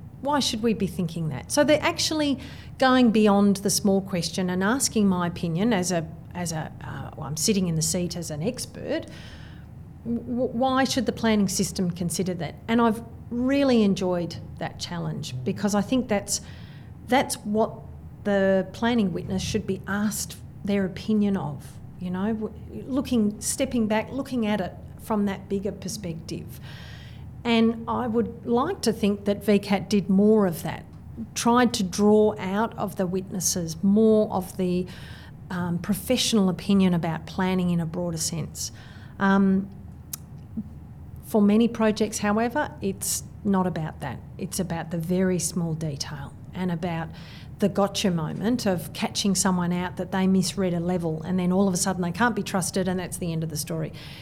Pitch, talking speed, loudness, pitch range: 195 Hz, 165 wpm, -25 LUFS, 175-215 Hz